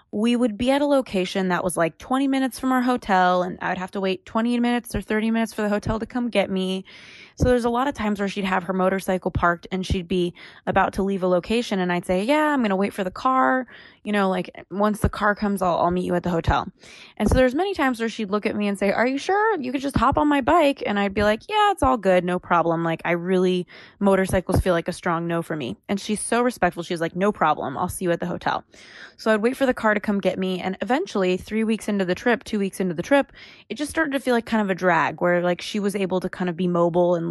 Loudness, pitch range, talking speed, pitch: -22 LUFS, 180-240 Hz, 280 wpm, 200 Hz